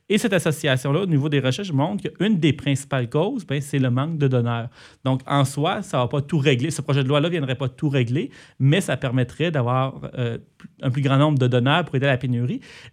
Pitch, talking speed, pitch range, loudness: 140 Hz, 235 wpm, 130-155 Hz, -22 LUFS